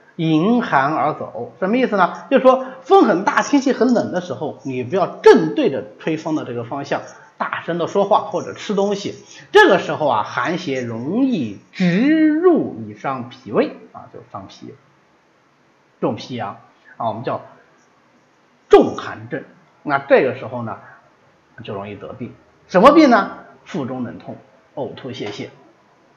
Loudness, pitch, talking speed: -17 LUFS, 220 Hz, 225 characters per minute